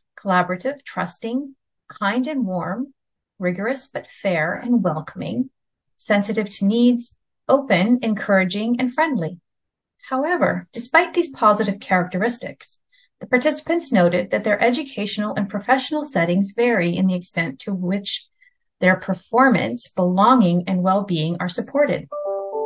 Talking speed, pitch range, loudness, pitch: 120 wpm, 185-260 Hz, -20 LUFS, 215 Hz